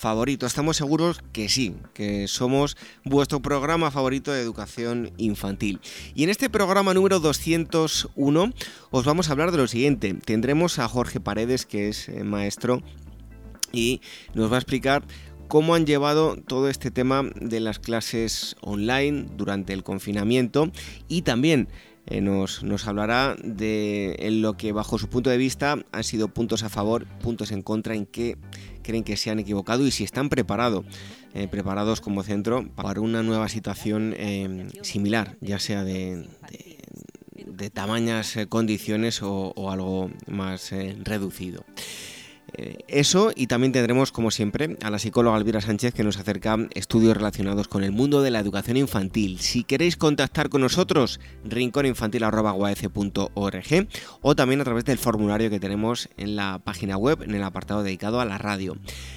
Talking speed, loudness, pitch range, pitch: 160 wpm, -24 LUFS, 100-130 Hz, 110 Hz